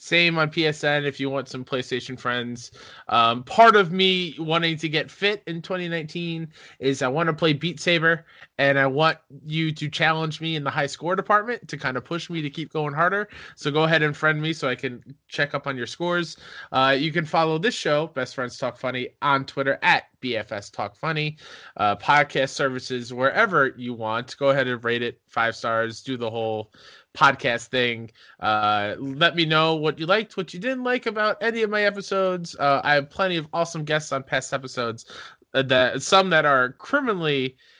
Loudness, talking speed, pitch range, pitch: -23 LUFS, 200 wpm, 130-170 Hz, 150 Hz